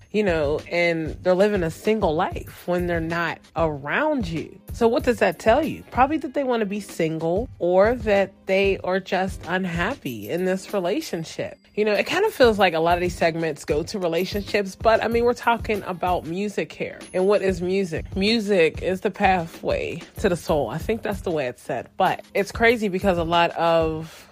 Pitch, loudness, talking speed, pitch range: 190 Hz, -23 LUFS, 205 wpm, 170-215 Hz